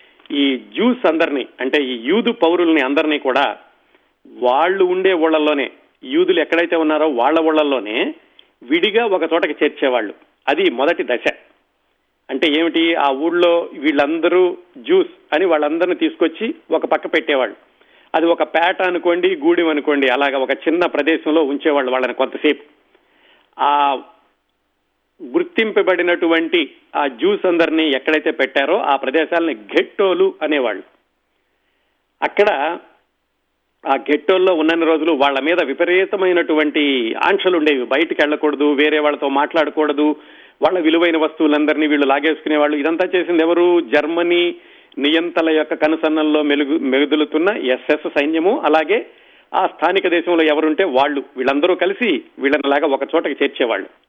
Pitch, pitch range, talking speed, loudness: 160 Hz, 145-175 Hz, 115 wpm, -16 LUFS